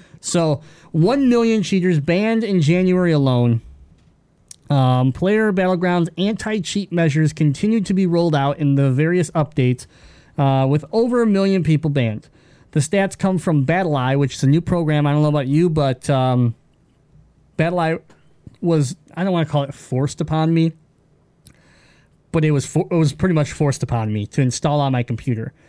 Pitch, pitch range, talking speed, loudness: 155 Hz, 140-175 Hz, 170 wpm, -18 LUFS